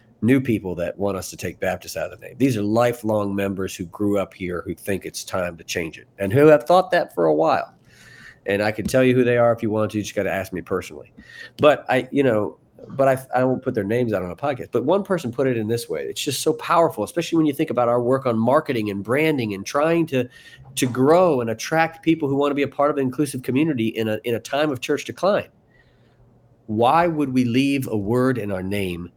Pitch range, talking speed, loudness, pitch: 110-145 Hz, 260 wpm, -21 LUFS, 125 Hz